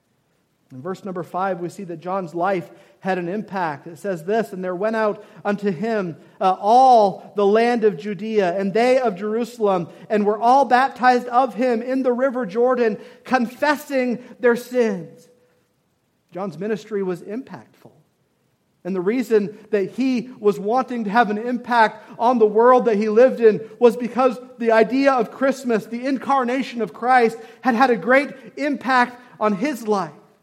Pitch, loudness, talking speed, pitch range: 225 Hz, -20 LUFS, 165 wpm, 200-250 Hz